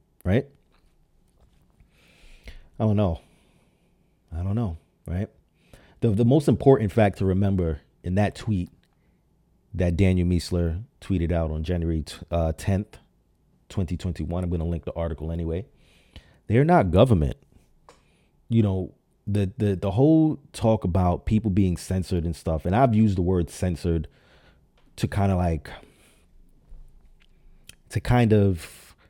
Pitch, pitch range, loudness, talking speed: 90 Hz, 85-105 Hz, -24 LUFS, 135 wpm